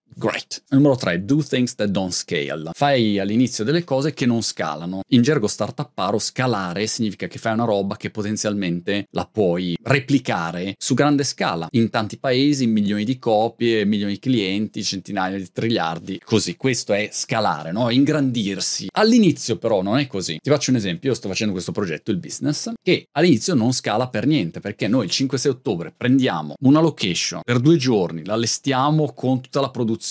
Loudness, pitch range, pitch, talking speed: -20 LUFS, 100-135 Hz, 115 Hz, 180 wpm